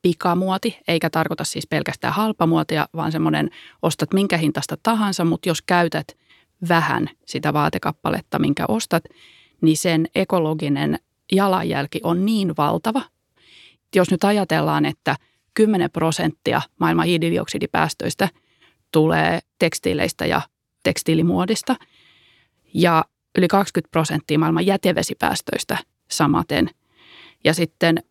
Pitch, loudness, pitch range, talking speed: 170 Hz, -20 LUFS, 160-190 Hz, 100 wpm